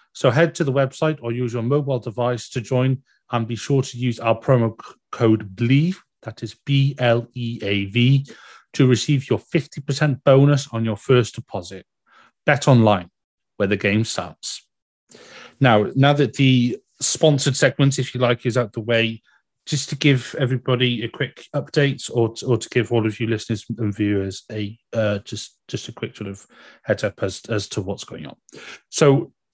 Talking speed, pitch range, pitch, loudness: 175 wpm, 115-135 Hz, 125 Hz, -20 LUFS